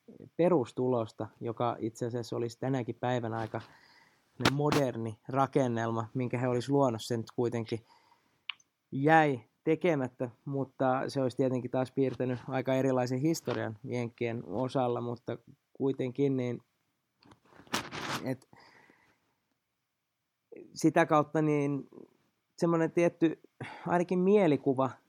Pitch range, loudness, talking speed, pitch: 120-140 Hz, -31 LUFS, 95 wpm, 130 Hz